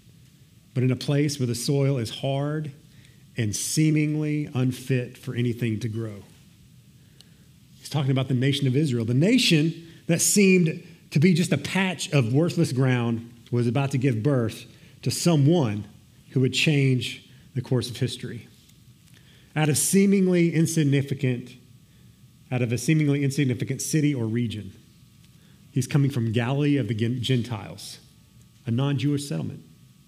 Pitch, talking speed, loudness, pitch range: 135 Hz, 145 wpm, -24 LUFS, 125-150 Hz